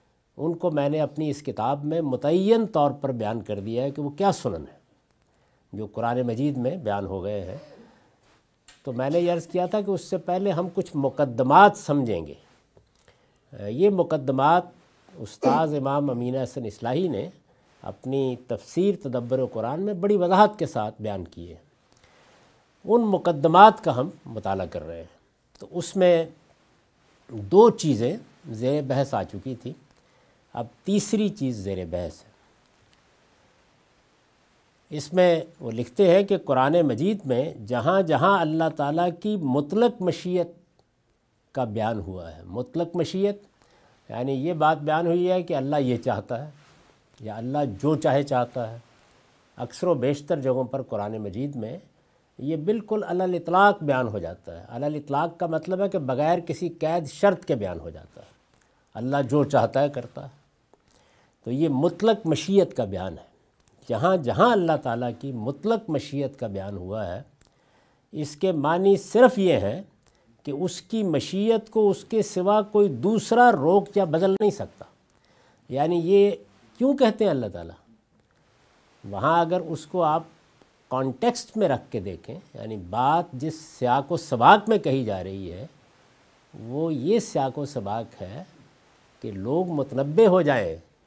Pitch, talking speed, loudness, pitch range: 145 Hz, 160 wpm, -24 LUFS, 120-180 Hz